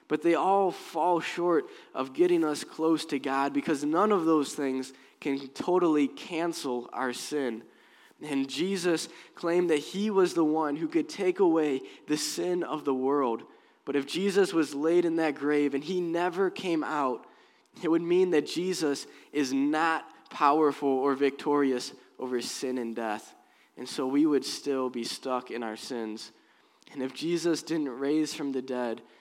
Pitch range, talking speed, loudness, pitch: 135-170 Hz, 170 wpm, -29 LUFS, 150 Hz